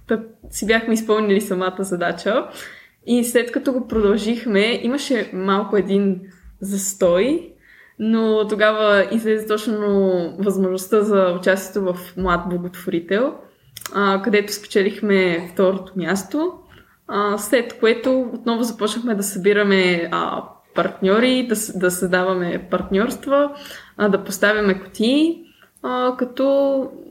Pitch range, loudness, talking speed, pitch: 190-235 Hz, -19 LUFS, 95 wpm, 205 Hz